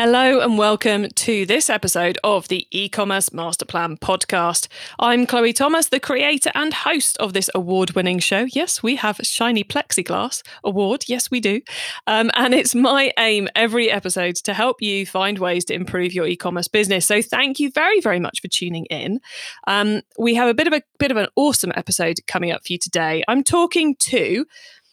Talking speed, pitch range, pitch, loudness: 190 wpm, 185-255 Hz, 215 Hz, -18 LUFS